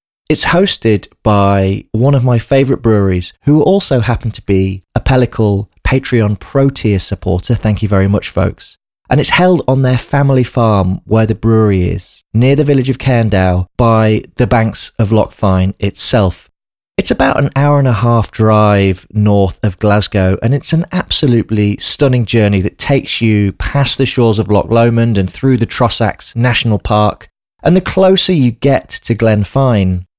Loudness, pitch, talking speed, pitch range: -12 LUFS, 110 Hz, 170 wpm, 100-130 Hz